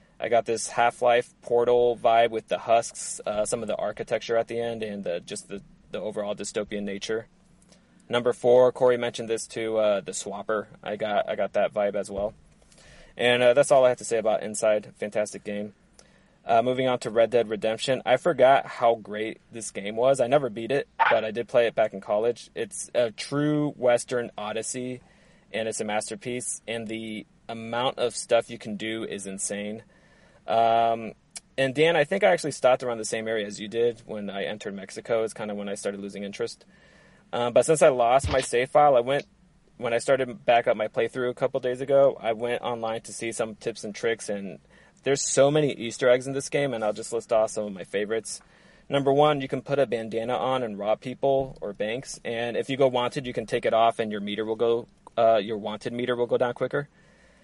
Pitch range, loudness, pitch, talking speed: 110-130 Hz, -25 LUFS, 120 Hz, 220 wpm